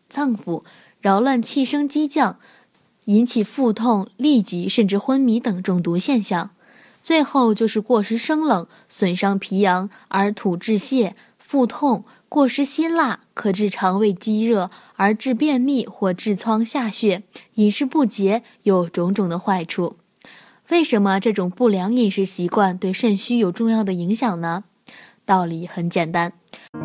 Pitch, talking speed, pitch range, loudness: 215 Hz, 215 characters per minute, 190-245 Hz, -20 LUFS